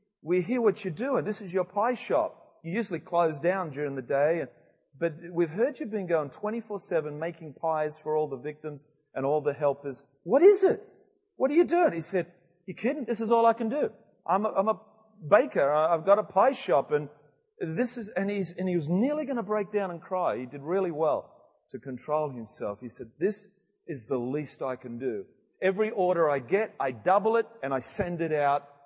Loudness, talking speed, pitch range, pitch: -28 LUFS, 220 wpm, 150-215 Hz, 180 Hz